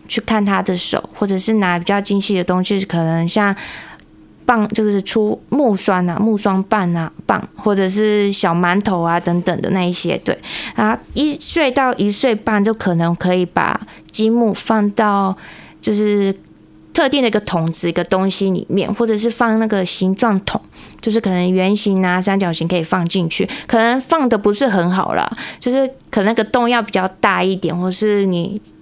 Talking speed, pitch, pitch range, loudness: 260 characters per minute, 200 Hz, 185-220 Hz, -16 LUFS